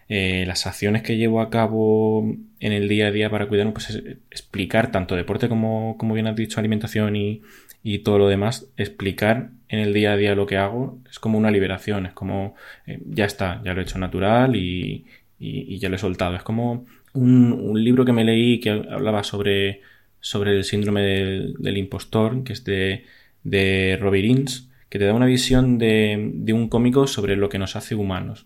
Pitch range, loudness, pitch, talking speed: 100-115 Hz, -21 LUFS, 105 Hz, 205 wpm